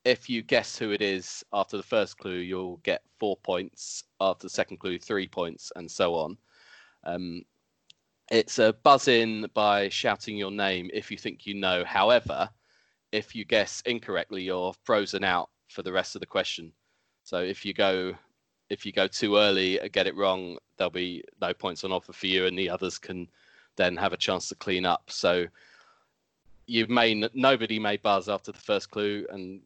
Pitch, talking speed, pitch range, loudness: 100 Hz, 190 wpm, 90-105 Hz, -27 LUFS